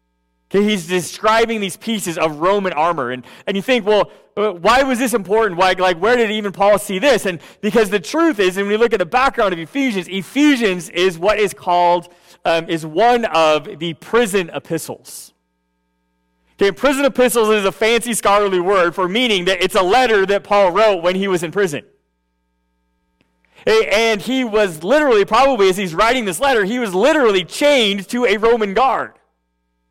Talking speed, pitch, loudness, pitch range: 180 wpm, 195 Hz, -16 LUFS, 170-225 Hz